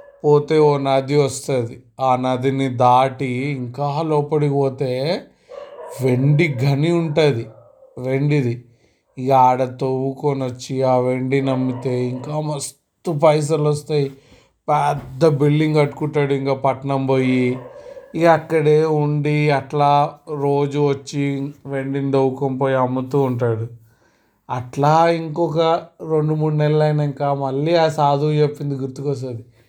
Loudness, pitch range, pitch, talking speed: -19 LUFS, 130-150 Hz, 140 Hz, 105 wpm